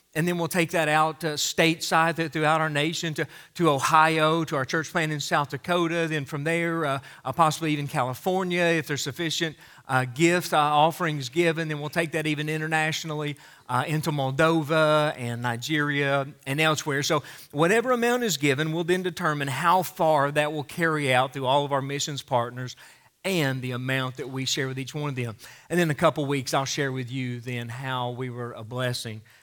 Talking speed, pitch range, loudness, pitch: 200 wpm, 135-165 Hz, -25 LUFS, 150 Hz